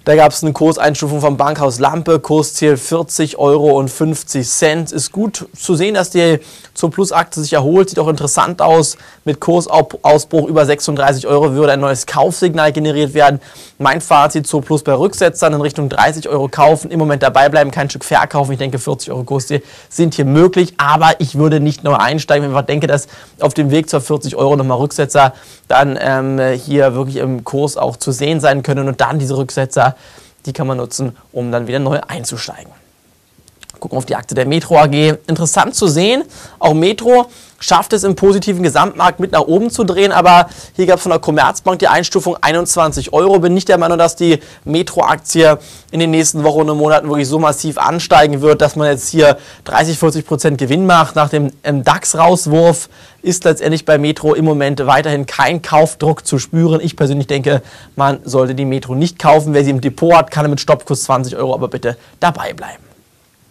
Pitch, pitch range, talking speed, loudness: 150 Hz, 140-165 Hz, 195 wpm, -13 LUFS